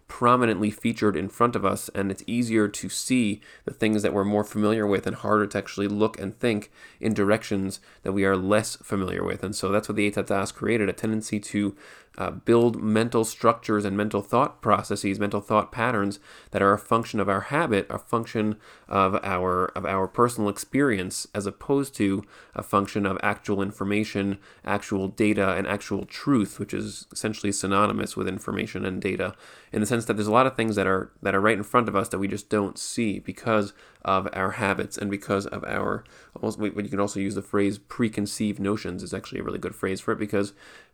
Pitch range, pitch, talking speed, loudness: 100-110 Hz, 105 Hz, 205 wpm, -26 LUFS